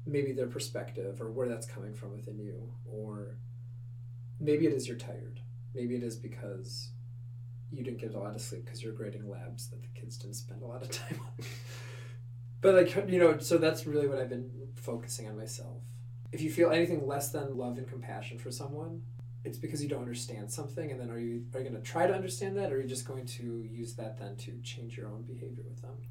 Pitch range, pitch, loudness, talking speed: 120-130 Hz, 120 Hz, -35 LUFS, 230 wpm